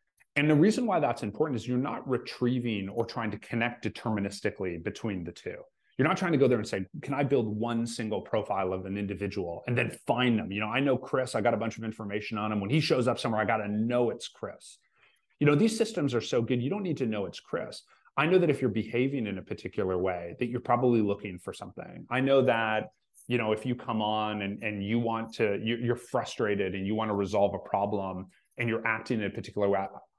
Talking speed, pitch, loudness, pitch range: 245 wpm, 115 Hz, -30 LUFS, 105-125 Hz